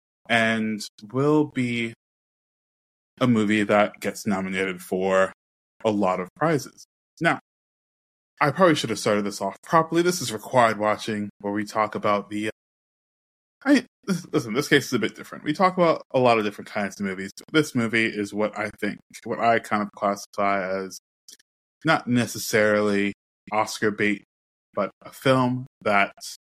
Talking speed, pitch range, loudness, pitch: 160 wpm, 100-120 Hz, -24 LUFS, 105 Hz